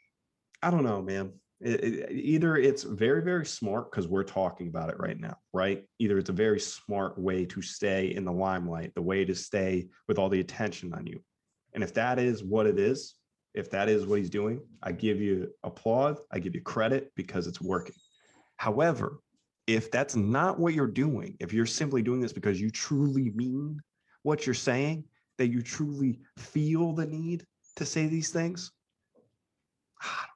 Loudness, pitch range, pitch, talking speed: -30 LUFS, 95-150 Hz, 120 Hz, 190 wpm